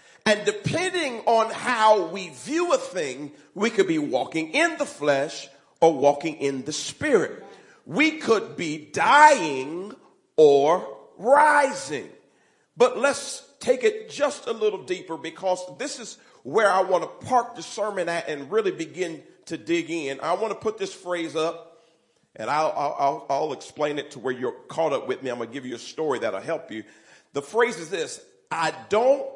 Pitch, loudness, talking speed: 225 Hz, -24 LUFS, 180 wpm